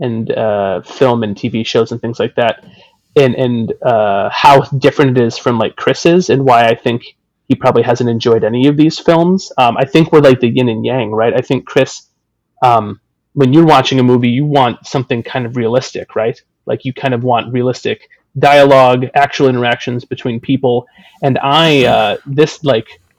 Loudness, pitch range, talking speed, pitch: -12 LUFS, 120-140 Hz, 195 wpm, 125 Hz